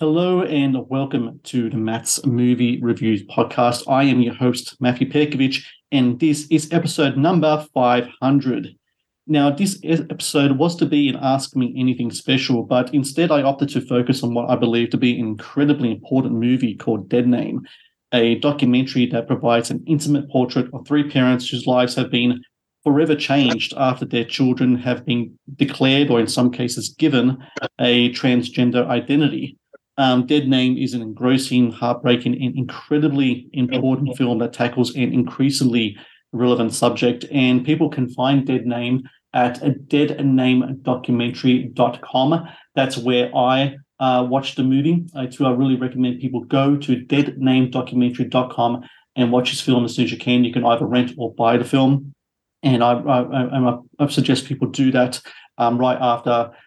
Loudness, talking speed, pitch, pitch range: -19 LUFS, 160 wpm, 130 Hz, 125-140 Hz